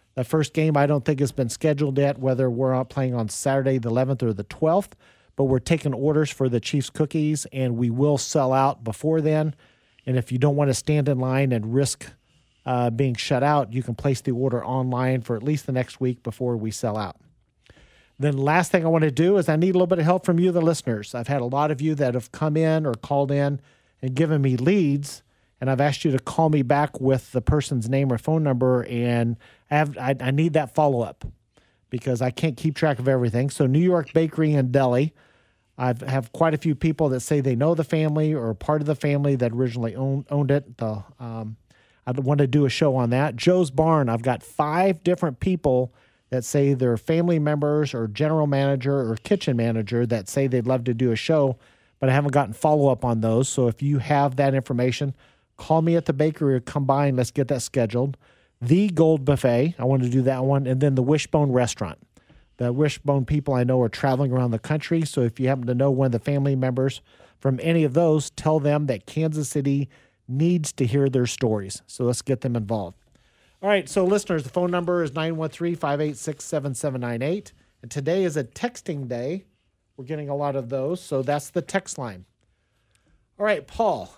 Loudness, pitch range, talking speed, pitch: -23 LUFS, 125-155 Hz, 220 wpm, 140 Hz